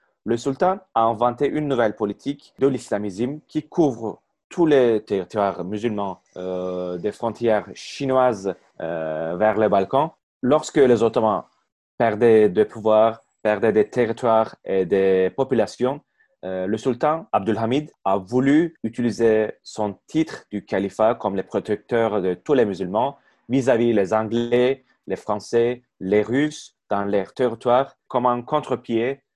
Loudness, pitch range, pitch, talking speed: -22 LUFS, 105-125 Hz, 115 Hz, 135 wpm